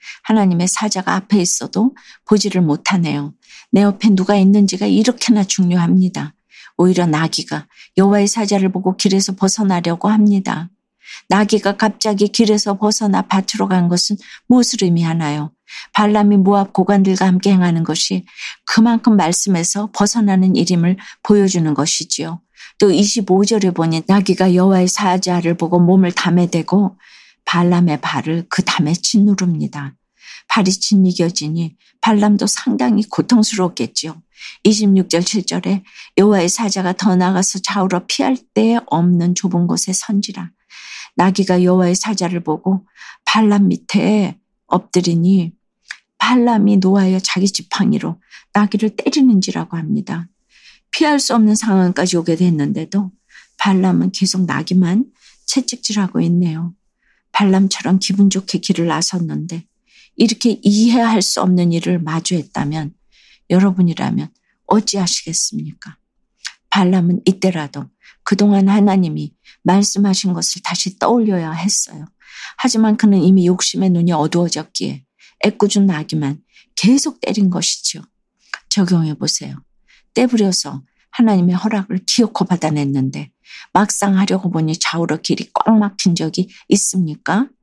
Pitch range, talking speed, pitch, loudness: 175-210 Hz, 300 characters per minute, 190 Hz, -15 LUFS